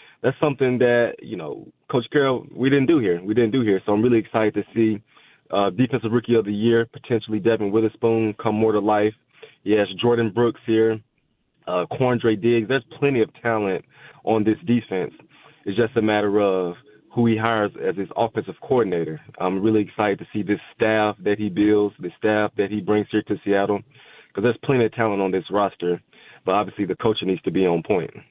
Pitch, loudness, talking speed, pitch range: 110 Hz, -22 LUFS, 200 wpm, 105-120 Hz